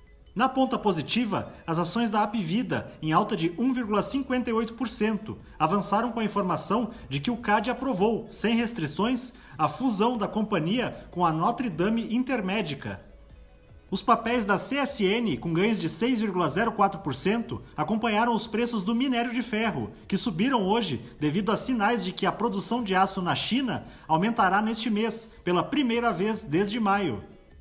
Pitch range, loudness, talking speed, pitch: 190-235 Hz, -26 LUFS, 150 wpm, 215 Hz